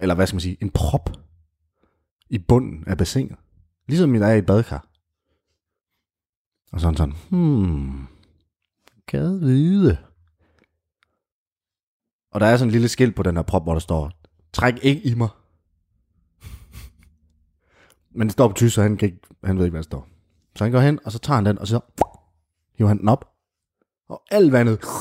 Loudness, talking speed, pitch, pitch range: -20 LUFS, 175 wpm, 95 Hz, 80-115 Hz